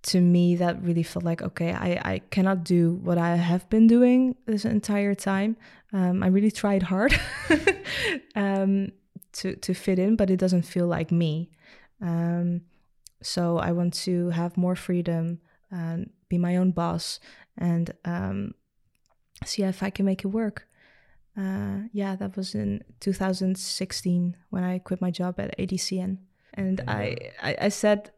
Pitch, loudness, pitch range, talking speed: 185 Hz, -26 LUFS, 175-200 Hz, 160 wpm